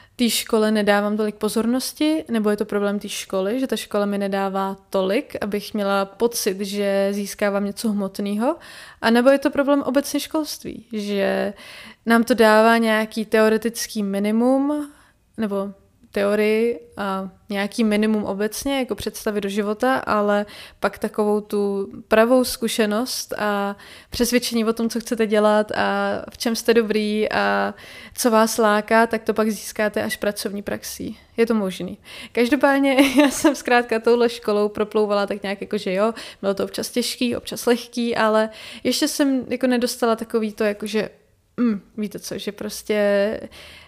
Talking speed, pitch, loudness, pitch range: 150 wpm, 220 Hz, -21 LUFS, 205-235 Hz